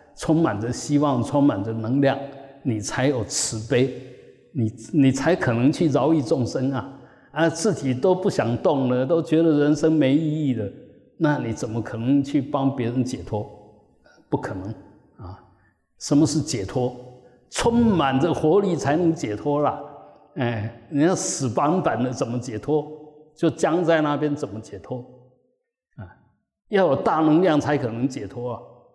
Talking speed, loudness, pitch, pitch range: 220 characters per minute, -22 LUFS, 135 Hz, 120-155 Hz